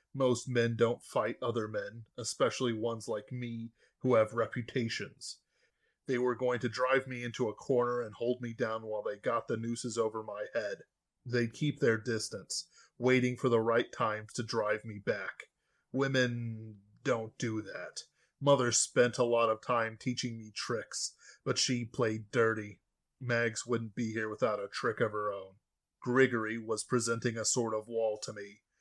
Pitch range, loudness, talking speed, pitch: 110-125 Hz, -33 LUFS, 175 wpm, 115 Hz